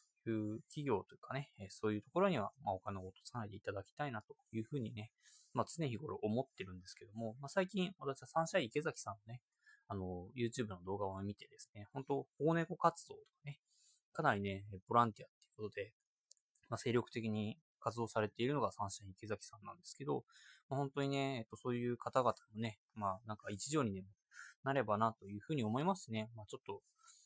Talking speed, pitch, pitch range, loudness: 420 characters per minute, 115 Hz, 105-145 Hz, -41 LUFS